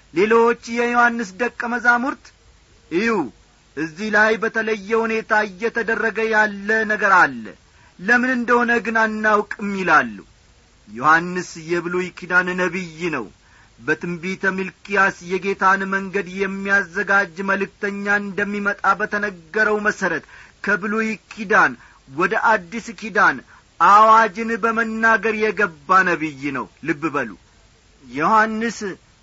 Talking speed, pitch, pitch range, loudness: 90 wpm, 205 Hz, 180-225 Hz, -19 LUFS